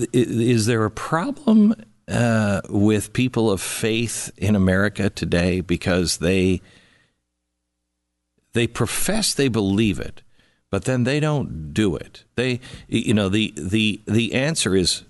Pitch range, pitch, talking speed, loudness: 95-120 Hz, 105 Hz, 130 wpm, -21 LUFS